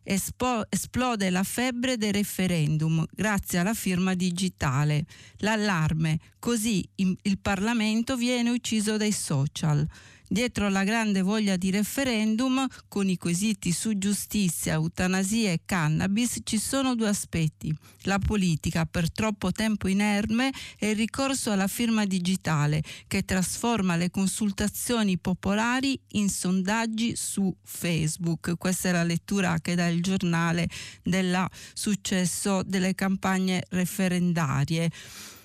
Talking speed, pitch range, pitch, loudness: 115 wpm, 175-215 Hz, 190 Hz, -27 LUFS